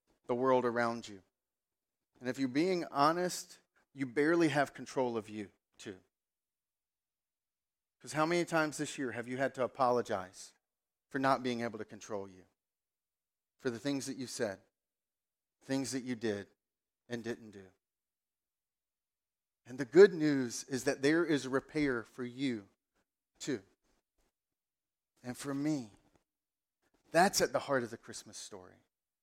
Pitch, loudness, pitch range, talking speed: 130 Hz, -34 LUFS, 115-140 Hz, 145 wpm